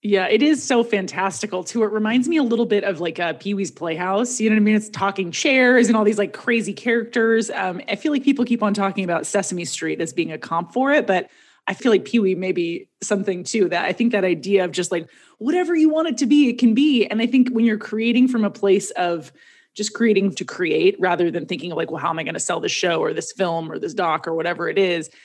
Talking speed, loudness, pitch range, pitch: 265 wpm, -20 LUFS, 185-235 Hz, 205 Hz